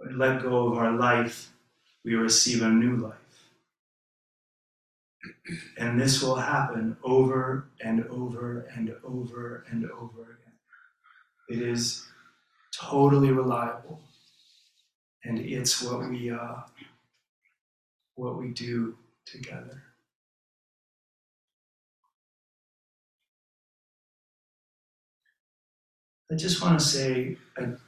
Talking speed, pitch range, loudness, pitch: 90 wpm, 115-130 Hz, -27 LUFS, 120 Hz